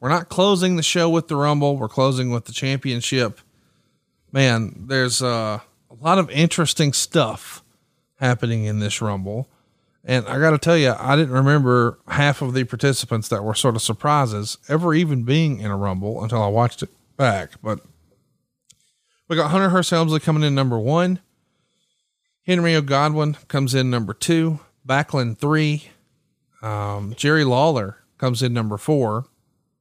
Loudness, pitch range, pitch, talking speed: -20 LUFS, 115-155 Hz, 135 Hz, 160 wpm